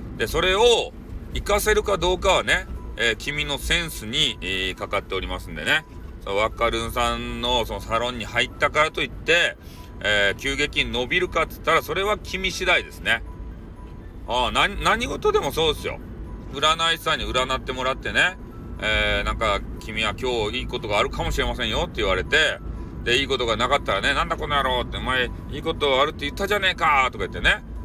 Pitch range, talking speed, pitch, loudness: 110-160 Hz, 395 characters per minute, 130 Hz, -22 LUFS